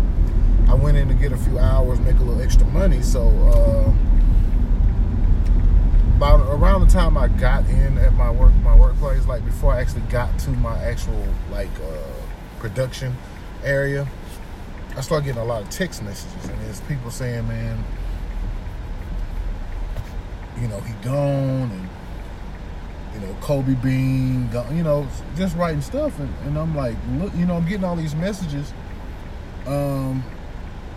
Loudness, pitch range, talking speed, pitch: -21 LUFS, 90-130 Hz, 155 wpm, 100 Hz